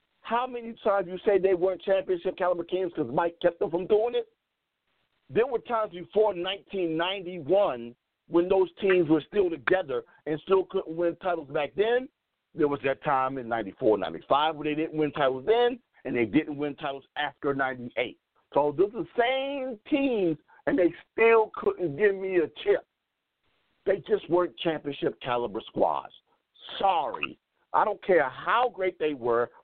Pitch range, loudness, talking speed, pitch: 150-215 Hz, -27 LUFS, 165 wpm, 180 Hz